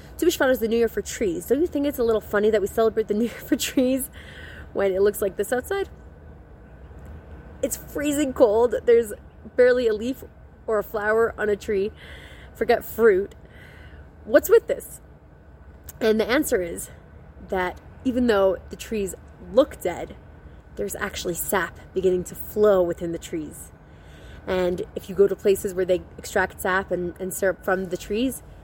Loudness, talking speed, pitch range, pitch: -23 LUFS, 175 wpm, 190-265 Hz, 210 Hz